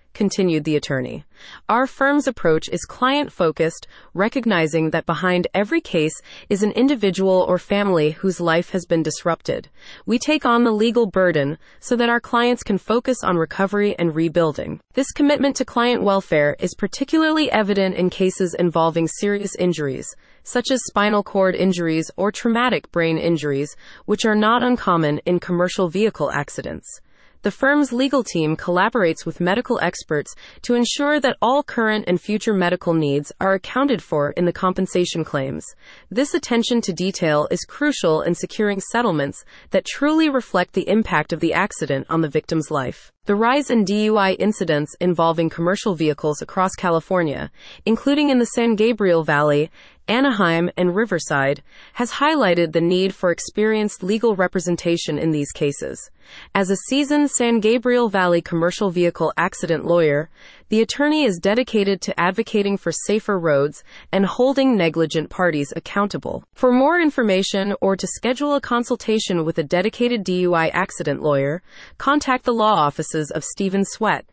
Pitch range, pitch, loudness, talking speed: 165-235 Hz, 190 Hz, -20 LUFS, 155 wpm